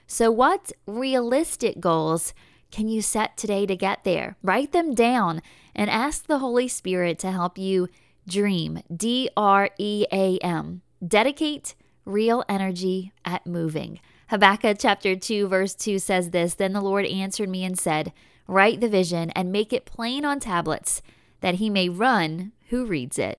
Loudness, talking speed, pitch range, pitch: -24 LUFS, 160 wpm, 180-230 Hz, 195 Hz